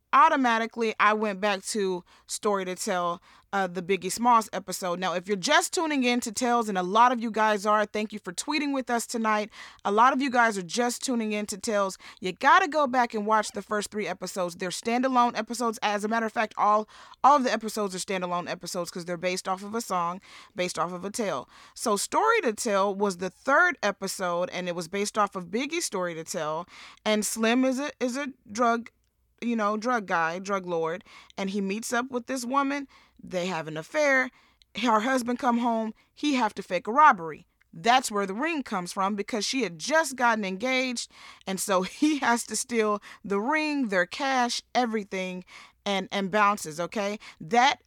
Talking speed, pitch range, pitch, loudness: 205 wpm, 190-245 Hz, 215 Hz, -26 LUFS